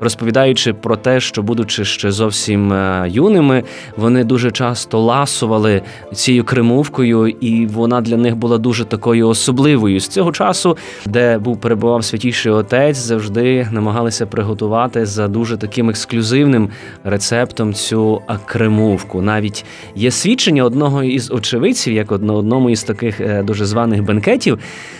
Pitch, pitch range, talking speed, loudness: 115 Hz, 110-125 Hz, 130 wpm, -14 LUFS